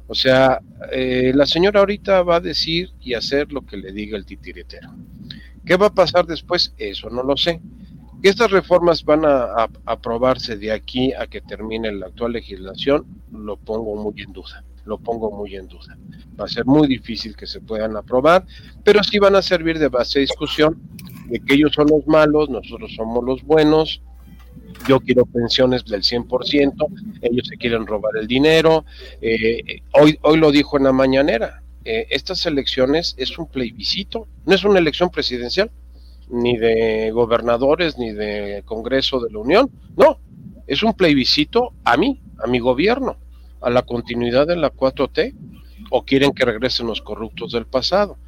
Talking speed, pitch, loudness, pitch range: 175 wpm, 130 Hz, -18 LUFS, 115-165 Hz